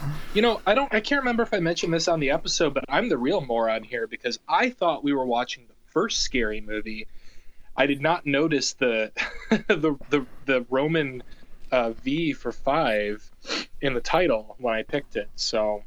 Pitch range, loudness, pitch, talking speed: 110-160 Hz, -25 LUFS, 135 Hz, 195 wpm